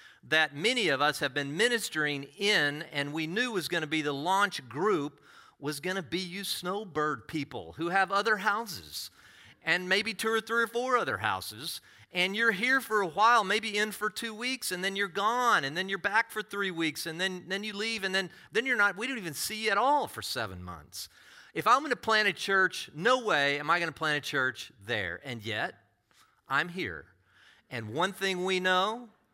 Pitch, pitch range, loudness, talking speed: 190 Hz, 155-215 Hz, -29 LUFS, 210 wpm